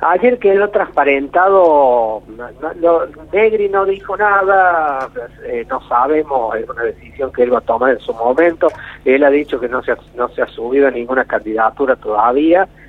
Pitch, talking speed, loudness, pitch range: 170 Hz, 180 wpm, -14 LUFS, 140-205 Hz